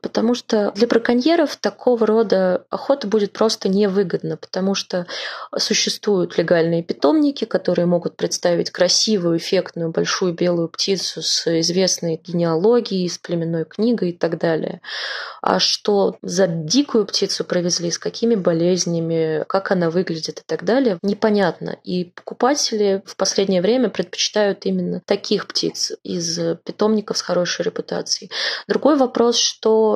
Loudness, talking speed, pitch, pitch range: -19 LUFS, 130 wpm, 195 Hz, 175-220 Hz